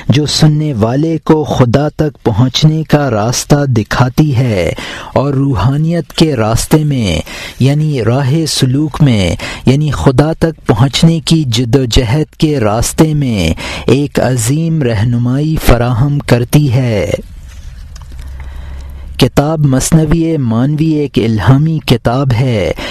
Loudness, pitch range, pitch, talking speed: -11 LUFS, 120-150 Hz, 135 Hz, 115 wpm